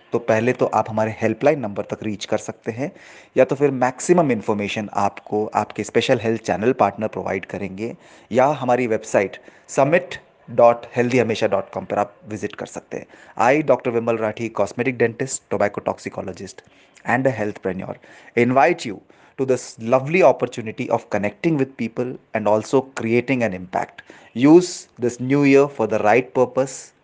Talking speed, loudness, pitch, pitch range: 165 wpm, -20 LUFS, 120 Hz, 110-130 Hz